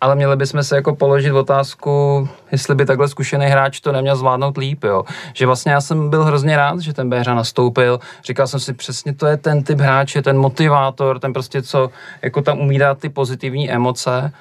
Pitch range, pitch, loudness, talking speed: 135-145 Hz, 140 Hz, -16 LUFS, 205 wpm